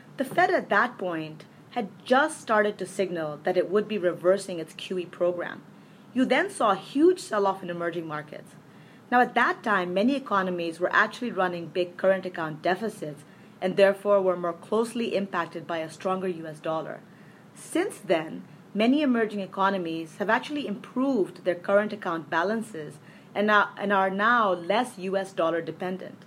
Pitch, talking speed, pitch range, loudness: 195 Hz, 160 wpm, 175-215 Hz, -26 LUFS